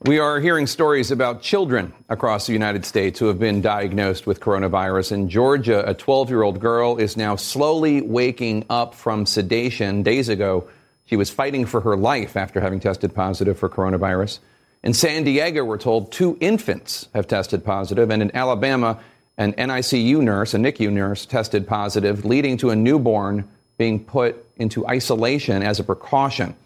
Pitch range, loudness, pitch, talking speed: 100-130 Hz, -20 LUFS, 115 Hz, 165 wpm